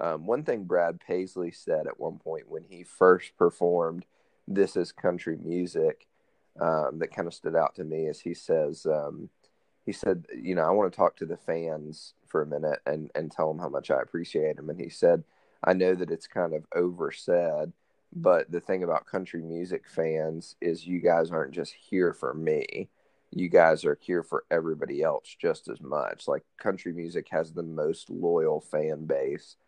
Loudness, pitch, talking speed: -29 LUFS, 90 Hz, 195 wpm